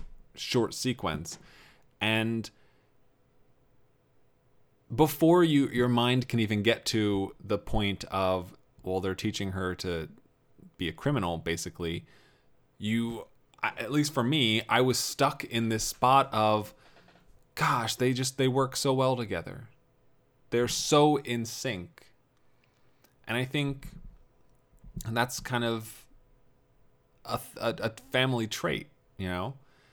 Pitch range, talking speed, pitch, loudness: 110-130 Hz, 120 wpm, 125 Hz, -29 LUFS